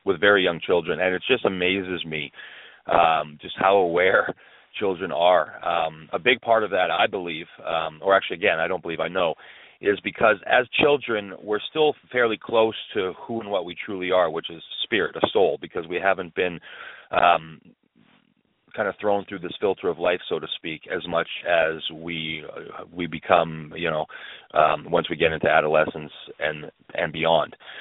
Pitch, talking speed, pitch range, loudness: 95 Hz, 185 wpm, 80-110 Hz, -23 LUFS